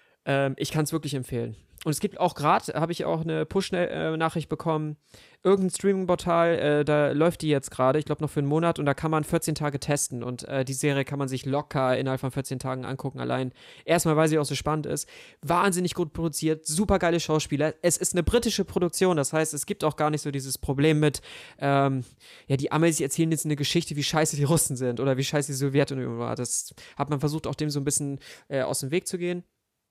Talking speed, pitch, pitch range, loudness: 225 wpm, 150 Hz, 140-165 Hz, -26 LUFS